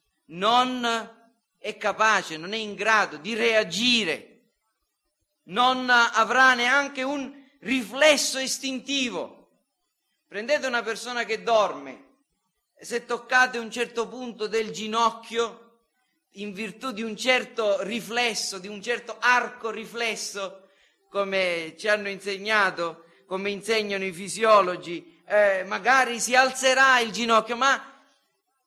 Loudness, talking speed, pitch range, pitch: -24 LUFS, 110 wpm, 205-250 Hz, 230 Hz